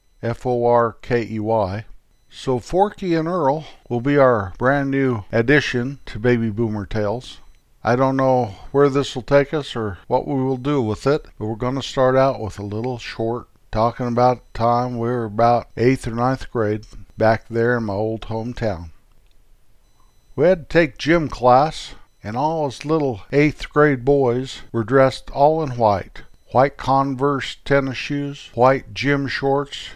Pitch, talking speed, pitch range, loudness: 125 Hz, 170 wpm, 115-140 Hz, -20 LUFS